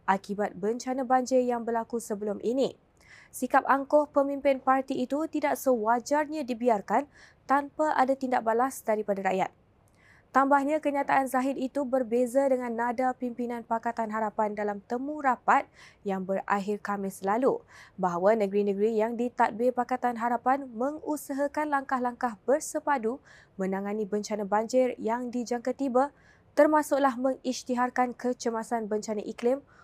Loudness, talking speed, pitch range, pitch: -28 LUFS, 115 wpm, 215-270 Hz, 245 Hz